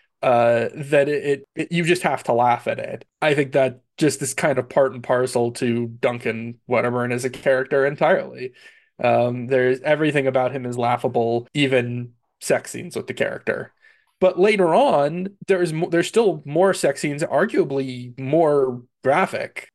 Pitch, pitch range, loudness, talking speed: 140 Hz, 125-170 Hz, -21 LUFS, 170 wpm